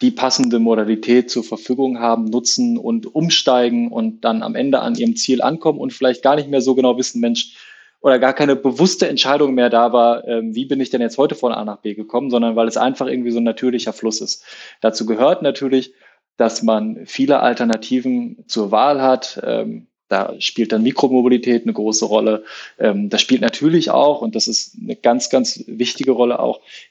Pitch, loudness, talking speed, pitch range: 125 Hz, -17 LUFS, 190 wpm, 115-140 Hz